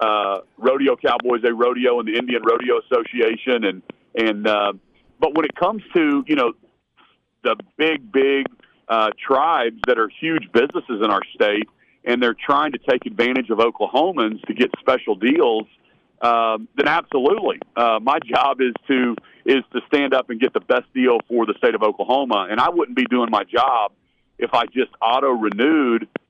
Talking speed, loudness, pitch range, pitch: 180 wpm, -19 LUFS, 115-160 Hz, 125 Hz